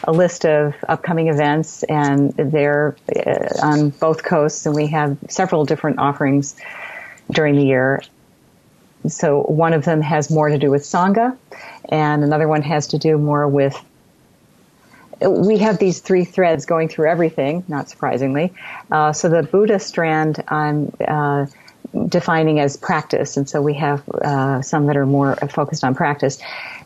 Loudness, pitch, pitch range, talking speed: -17 LUFS, 150 Hz, 145-165 Hz, 155 wpm